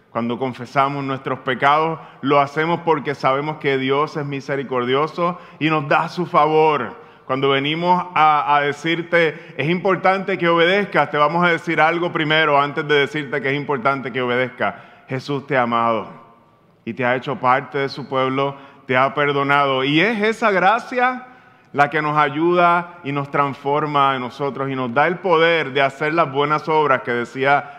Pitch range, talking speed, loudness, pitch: 135-165 Hz, 175 wpm, -18 LUFS, 145 Hz